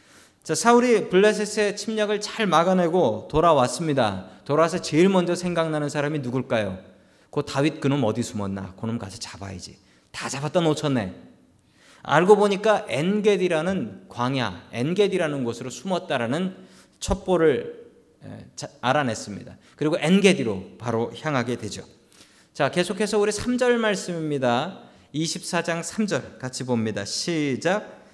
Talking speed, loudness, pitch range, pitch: 290 characters per minute, -23 LUFS, 120-195 Hz, 155 Hz